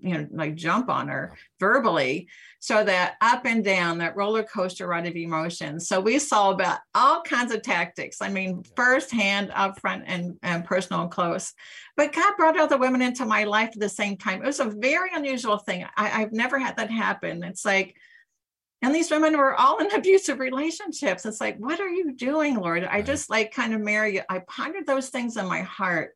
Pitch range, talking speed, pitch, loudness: 190-275 Hz, 210 wpm, 220 Hz, -24 LUFS